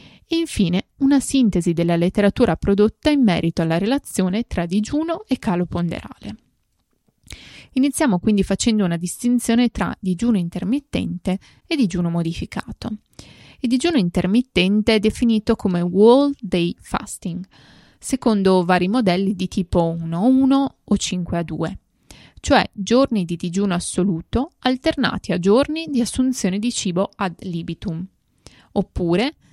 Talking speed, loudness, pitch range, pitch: 120 wpm, -20 LUFS, 180-245 Hz, 205 Hz